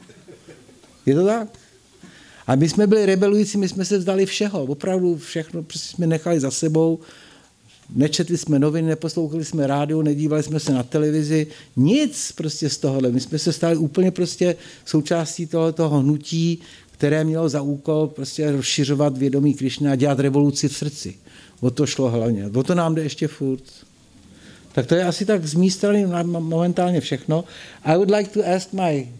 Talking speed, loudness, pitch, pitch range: 170 wpm, -21 LUFS, 160 Hz, 145-175 Hz